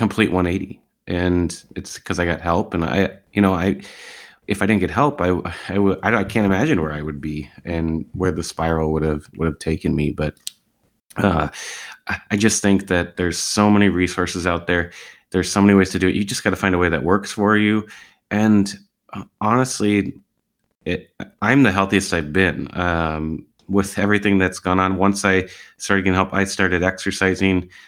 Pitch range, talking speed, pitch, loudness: 85-100 Hz, 195 wpm, 95 Hz, -19 LUFS